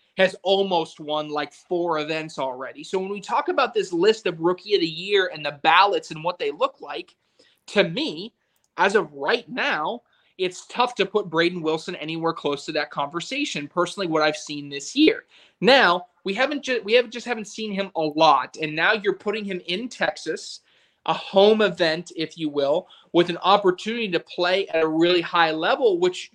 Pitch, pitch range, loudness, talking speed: 180 Hz, 160-210 Hz, -23 LUFS, 195 wpm